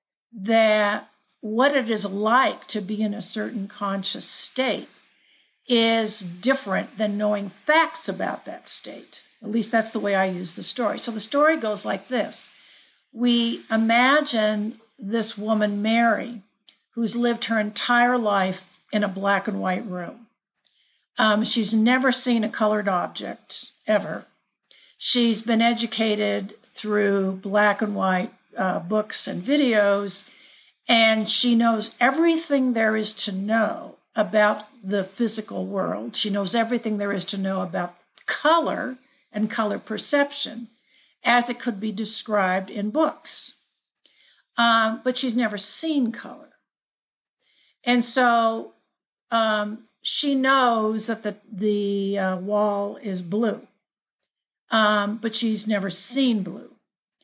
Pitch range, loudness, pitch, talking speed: 205-240 Hz, -23 LUFS, 220 Hz, 130 wpm